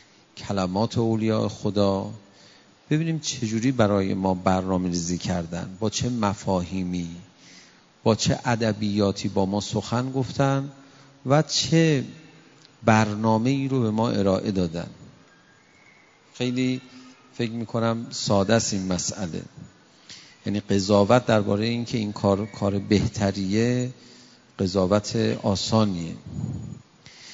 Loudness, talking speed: -24 LUFS, 105 wpm